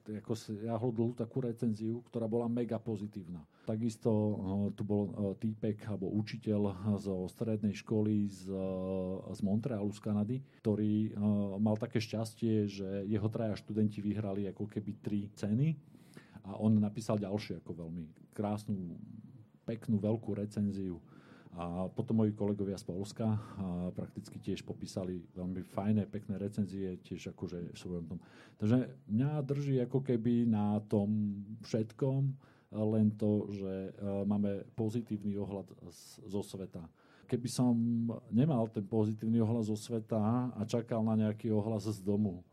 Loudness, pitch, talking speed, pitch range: -36 LUFS, 105 Hz, 135 wpm, 100-115 Hz